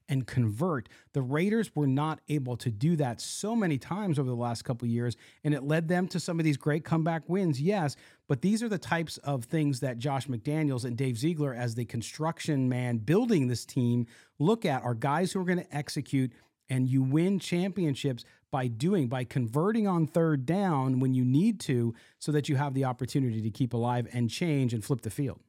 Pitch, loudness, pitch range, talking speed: 140 Hz, -30 LUFS, 125-165 Hz, 210 wpm